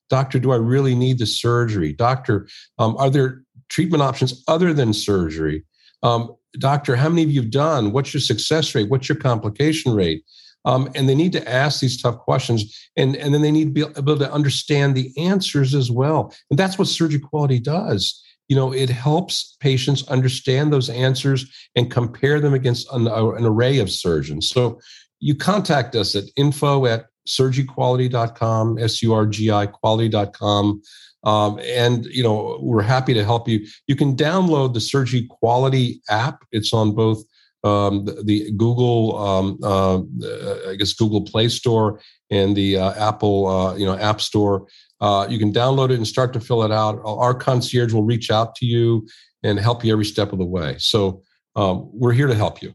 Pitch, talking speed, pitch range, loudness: 120 Hz, 185 wpm, 105-135 Hz, -19 LUFS